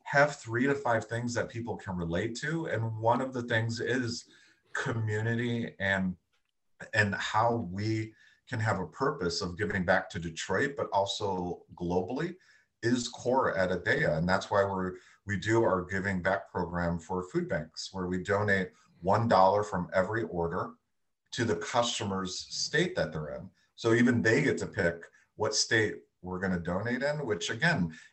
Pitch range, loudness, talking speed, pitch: 90-115 Hz, -30 LUFS, 170 wpm, 105 Hz